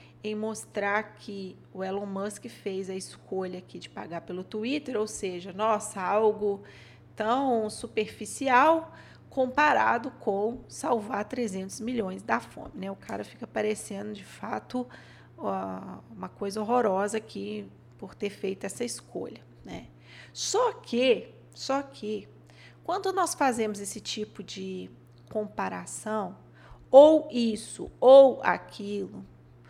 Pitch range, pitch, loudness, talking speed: 190-240 Hz, 210 Hz, -28 LUFS, 120 wpm